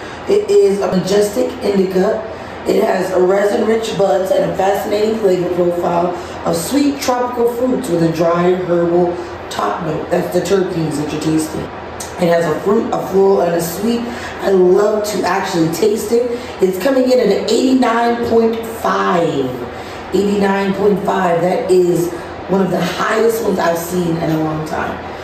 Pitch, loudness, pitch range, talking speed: 190 Hz, -15 LUFS, 175-215 Hz, 155 wpm